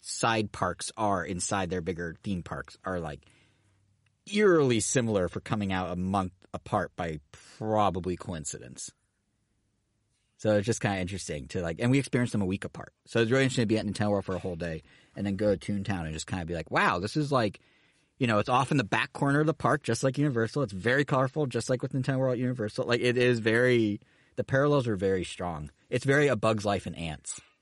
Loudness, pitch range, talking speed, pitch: -29 LUFS, 95-125 Hz, 225 wpm, 105 Hz